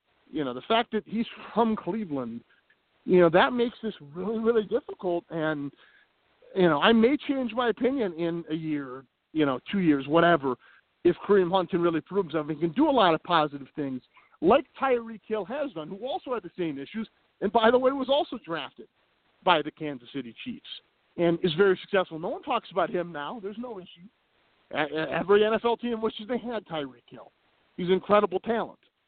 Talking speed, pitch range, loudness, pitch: 195 wpm, 165-230 Hz, -27 LUFS, 195 Hz